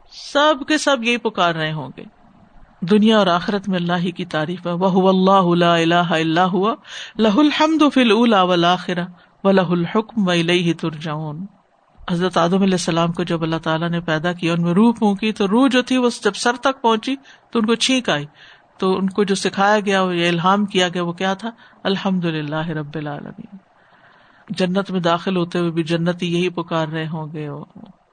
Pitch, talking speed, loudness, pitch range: 185 Hz, 165 wpm, -18 LUFS, 170-215 Hz